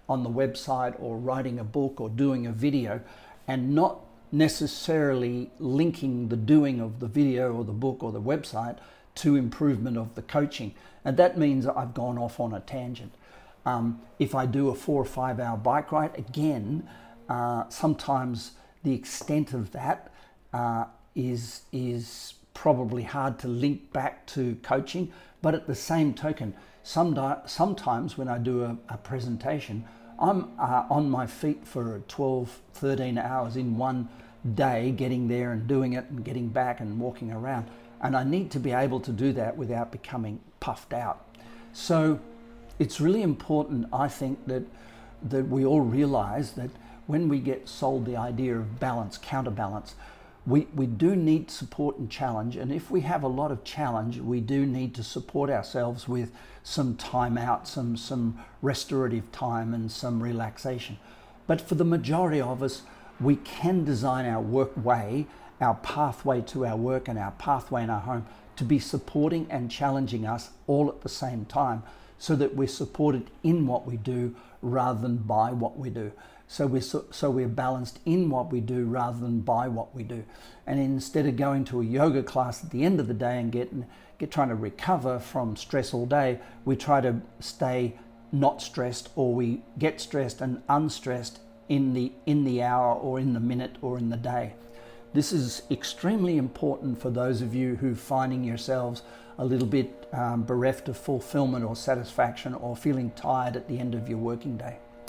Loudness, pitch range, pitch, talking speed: -28 LUFS, 120-140 Hz, 125 Hz, 180 wpm